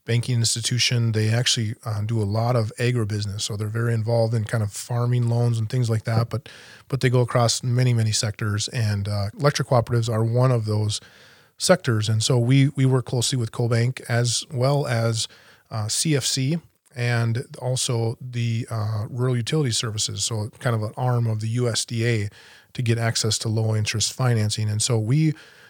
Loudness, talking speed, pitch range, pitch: -23 LUFS, 180 wpm, 110-125 Hz, 115 Hz